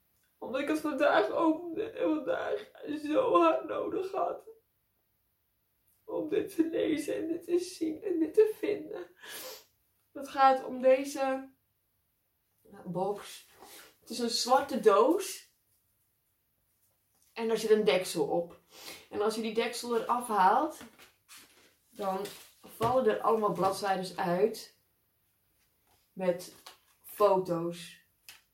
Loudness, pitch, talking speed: -30 LUFS, 260 Hz, 115 wpm